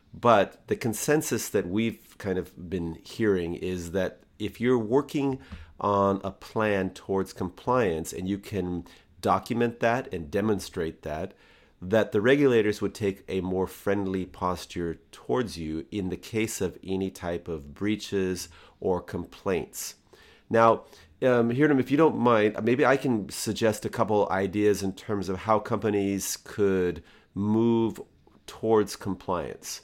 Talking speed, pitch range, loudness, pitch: 145 wpm, 90-110 Hz, -27 LUFS, 100 Hz